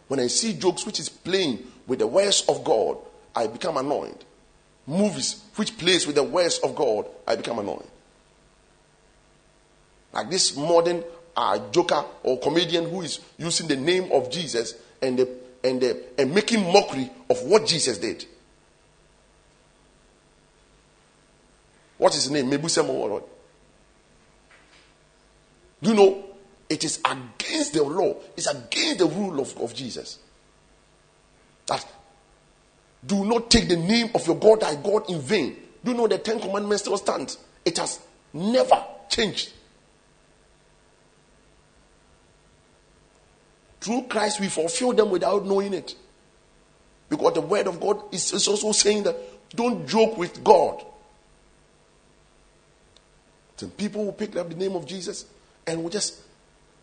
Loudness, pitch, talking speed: -24 LUFS, 175 Hz, 135 wpm